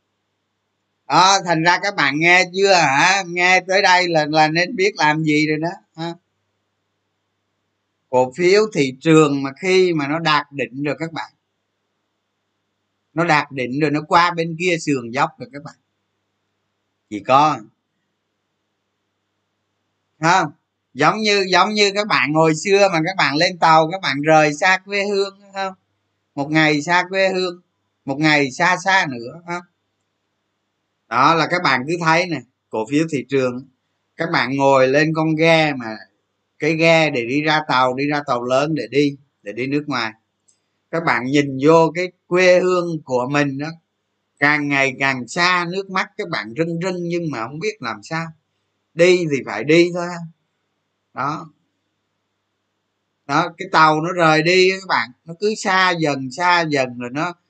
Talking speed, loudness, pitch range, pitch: 170 wpm, -17 LUFS, 110-175 Hz, 150 Hz